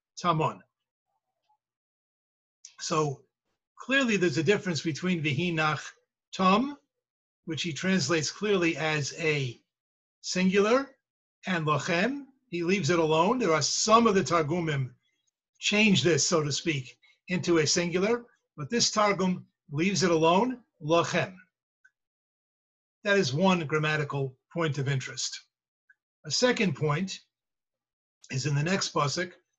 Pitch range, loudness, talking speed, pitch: 155-205 Hz, -27 LUFS, 120 wpm, 175 Hz